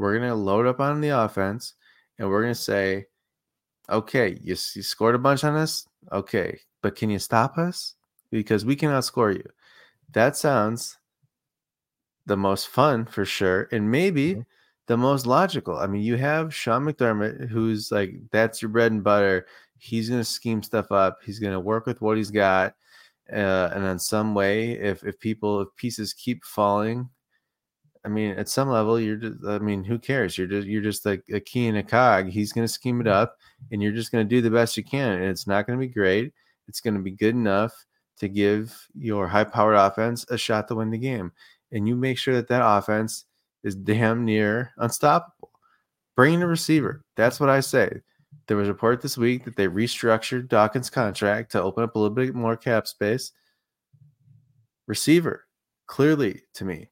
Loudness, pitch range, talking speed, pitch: -24 LUFS, 105-125 Hz, 195 wpm, 110 Hz